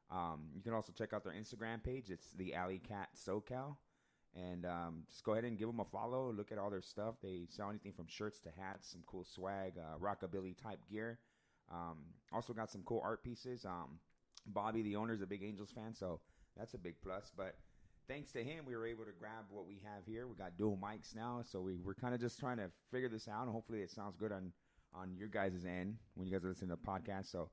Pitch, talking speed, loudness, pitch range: 100 Hz, 240 wpm, -47 LUFS, 95-115 Hz